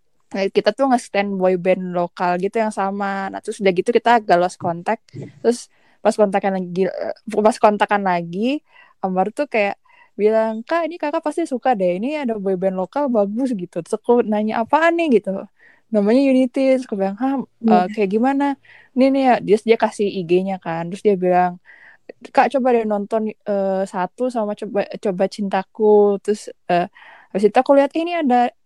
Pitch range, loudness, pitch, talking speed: 195-255 Hz, -19 LUFS, 210 Hz, 190 wpm